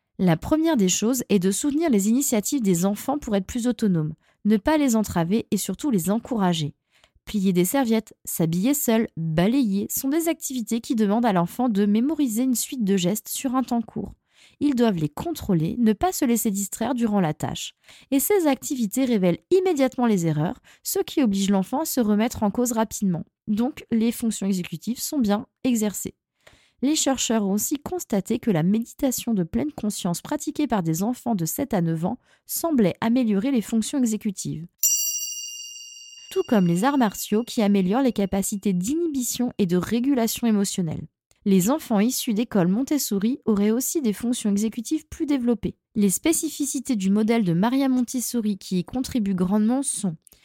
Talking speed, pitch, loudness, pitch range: 170 wpm, 225 Hz, -23 LUFS, 200-265 Hz